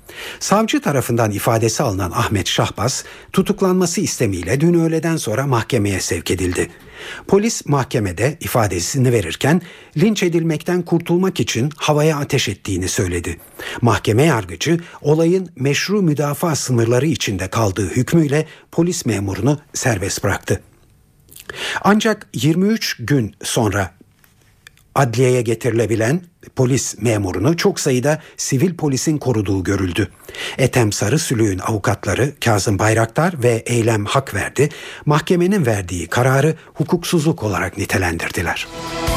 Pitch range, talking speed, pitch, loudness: 110-160 Hz, 105 wpm, 130 Hz, -18 LUFS